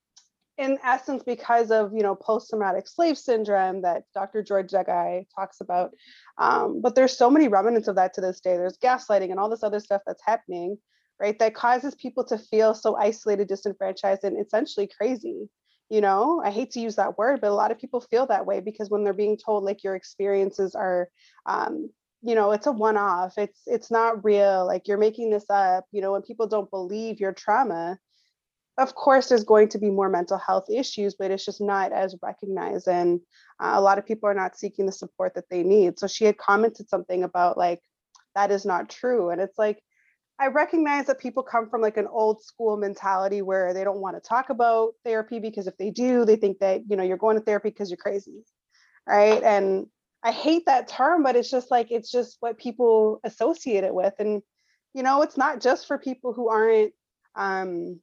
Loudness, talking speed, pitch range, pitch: -24 LUFS, 210 wpm, 195-235 Hz, 210 Hz